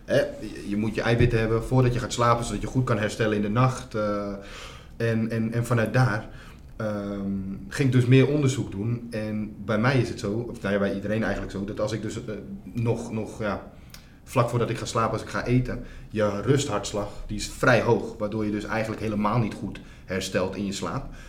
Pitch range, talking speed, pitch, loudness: 105-120 Hz, 215 wpm, 110 Hz, -26 LUFS